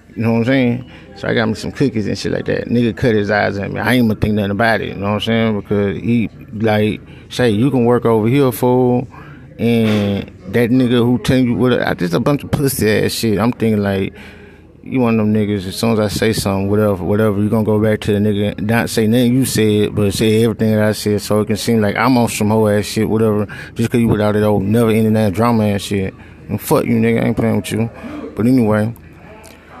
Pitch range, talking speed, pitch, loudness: 105-120 Hz, 260 wpm, 110 Hz, -15 LUFS